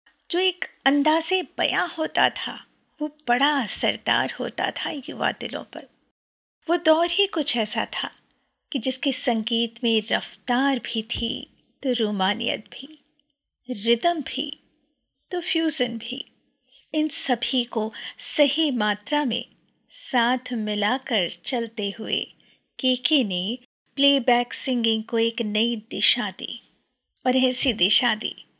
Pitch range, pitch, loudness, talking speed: 230-290 Hz, 250 Hz, -24 LUFS, 120 wpm